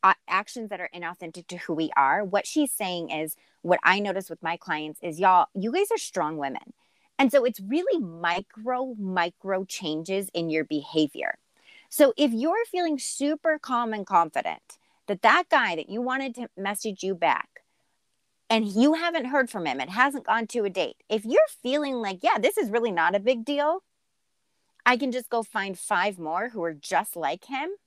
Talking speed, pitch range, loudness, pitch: 190 wpm, 180-260 Hz, -26 LUFS, 215 Hz